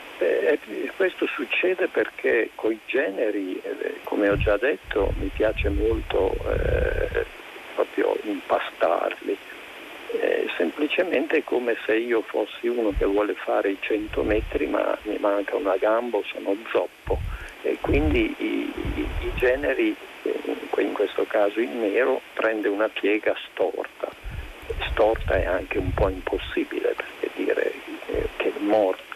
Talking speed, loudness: 130 wpm, -25 LUFS